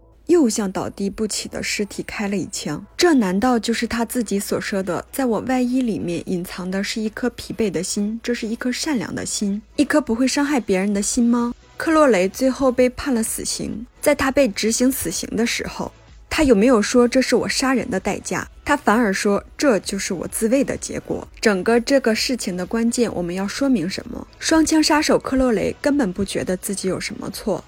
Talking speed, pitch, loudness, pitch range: 300 characters per minute, 230 Hz, -20 LUFS, 200-260 Hz